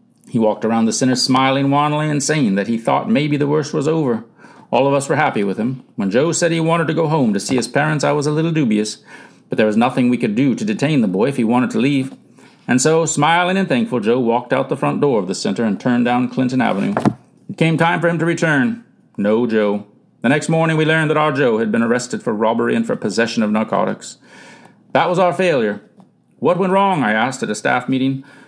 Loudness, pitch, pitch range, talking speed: -17 LUFS, 150 Hz, 125-170 Hz, 245 wpm